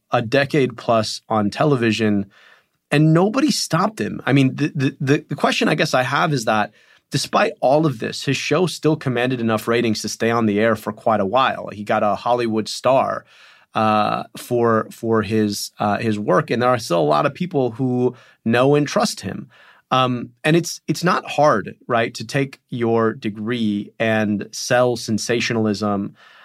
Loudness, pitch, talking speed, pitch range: -19 LUFS, 120 Hz, 180 wpm, 110-145 Hz